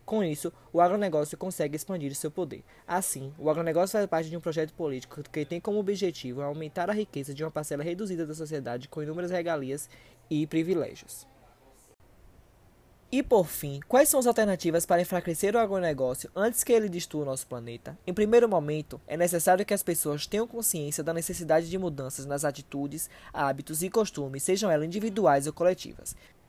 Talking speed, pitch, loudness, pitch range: 175 wpm, 165 Hz, -29 LUFS, 145-185 Hz